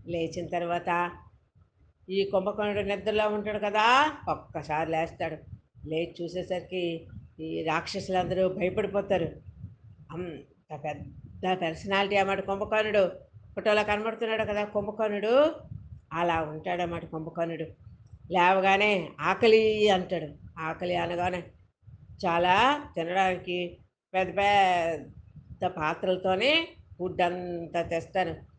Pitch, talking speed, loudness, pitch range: 180 Hz, 85 wpm, -28 LUFS, 165-200 Hz